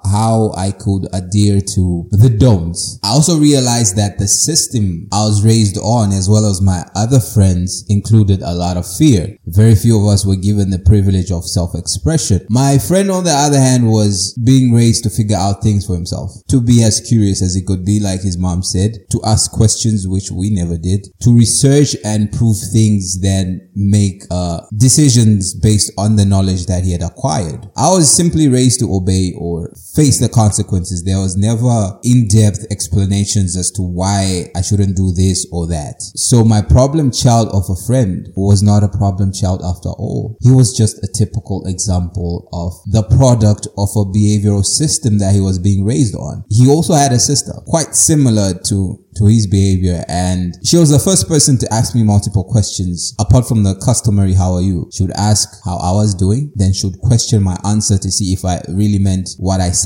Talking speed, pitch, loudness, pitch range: 195 wpm, 105 Hz, -13 LUFS, 95-115 Hz